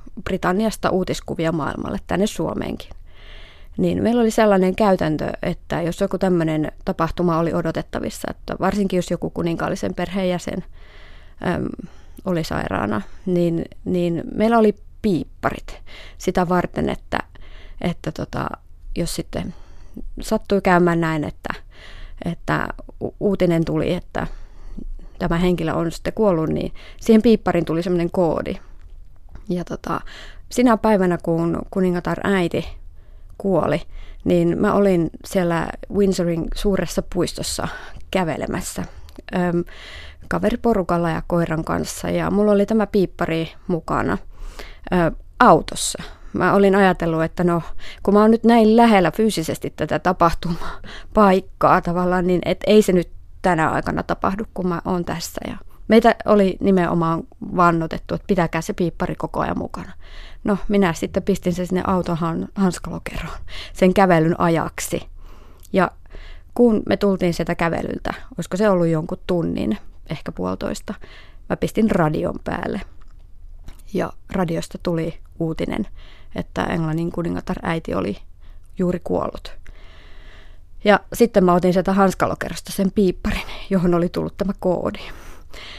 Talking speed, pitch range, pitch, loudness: 125 wpm, 155-190 Hz, 175 Hz, -20 LUFS